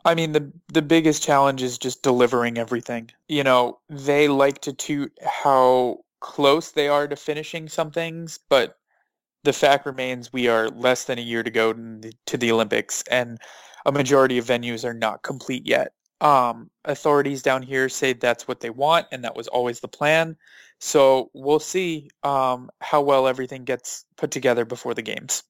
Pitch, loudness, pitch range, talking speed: 135 Hz, -22 LUFS, 125-150 Hz, 180 wpm